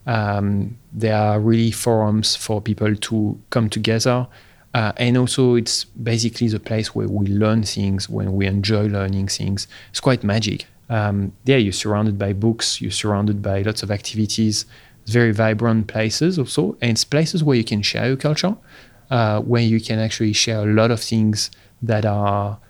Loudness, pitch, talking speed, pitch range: -19 LUFS, 110 Hz, 175 wpm, 105-115 Hz